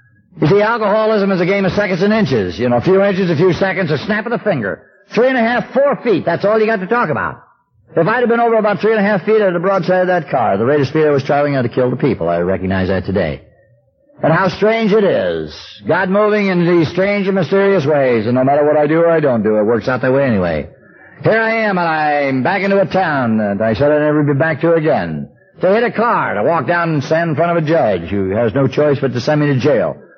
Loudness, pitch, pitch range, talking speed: -14 LUFS, 165 Hz, 135-200 Hz, 280 wpm